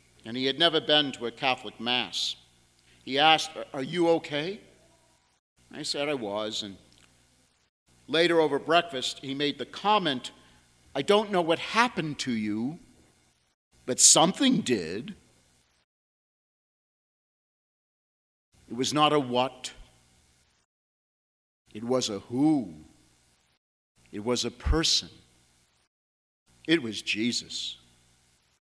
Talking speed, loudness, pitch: 110 wpm, -26 LUFS, 110 Hz